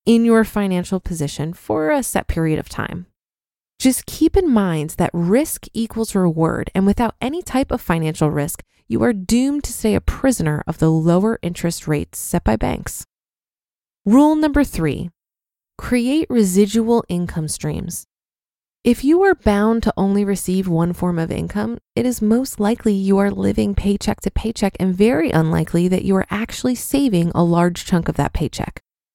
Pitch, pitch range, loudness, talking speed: 200 Hz, 170-230 Hz, -18 LUFS, 170 wpm